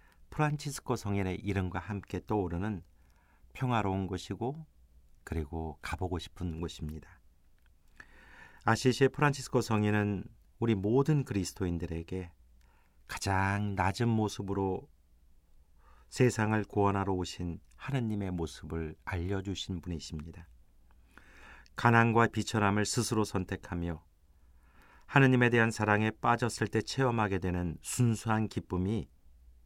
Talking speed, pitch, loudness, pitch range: 265 characters per minute, 95 Hz, -32 LUFS, 80-110 Hz